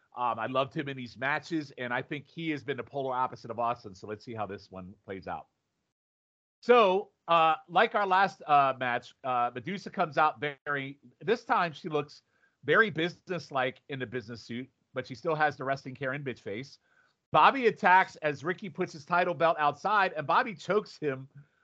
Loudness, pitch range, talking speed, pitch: -29 LUFS, 125-175 Hz, 195 wpm, 145 Hz